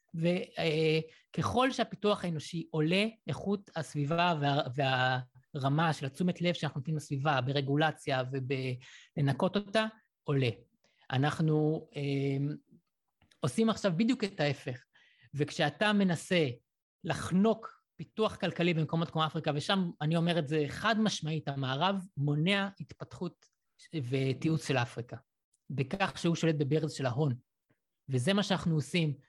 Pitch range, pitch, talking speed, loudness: 140-180 Hz, 155 Hz, 115 wpm, -32 LUFS